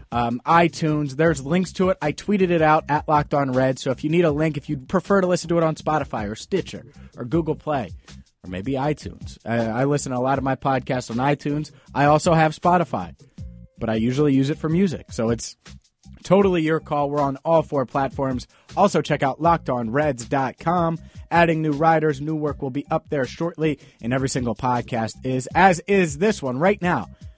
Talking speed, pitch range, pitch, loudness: 205 wpm, 130-165 Hz, 145 Hz, -22 LUFS